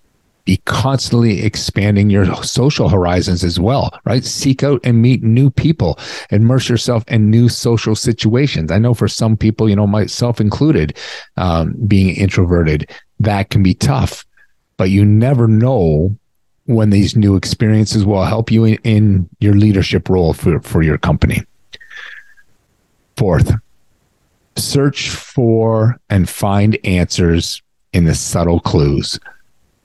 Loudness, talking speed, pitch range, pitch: -14 LUFS, 135 wpm, 95-120 Hz, 110 Hz